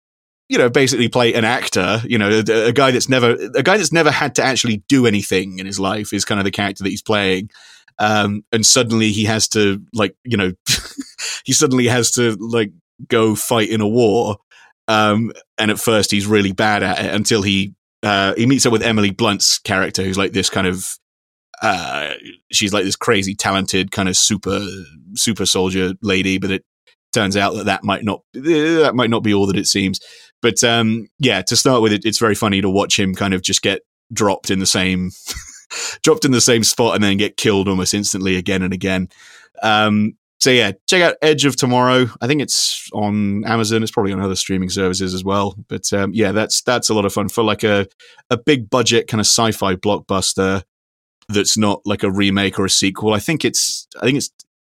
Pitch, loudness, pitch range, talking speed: 105 Hz, -16 LUFS, 95-115 Hz, 210 wpm